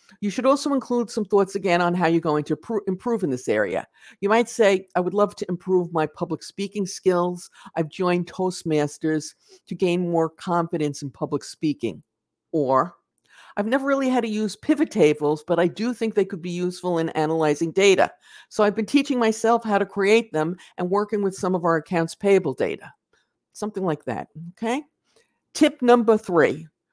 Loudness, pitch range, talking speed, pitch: -23 LUFS, 165-220 Hz, 185 wpm, 190 Hz